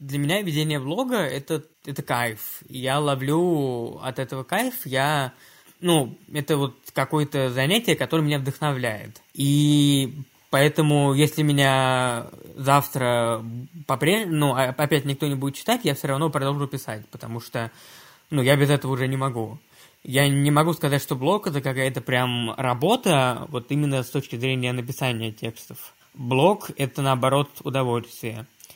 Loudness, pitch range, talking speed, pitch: -23 LUFS, 130-150 Hz, 140 wpm, 140 Hz